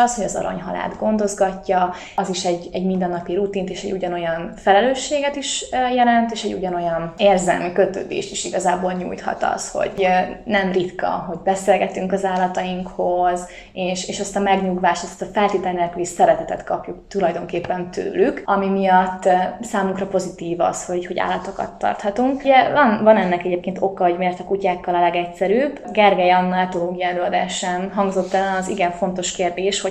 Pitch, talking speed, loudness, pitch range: 185 Hz, 155 wpm, -20 LUFS, 180-200 Hz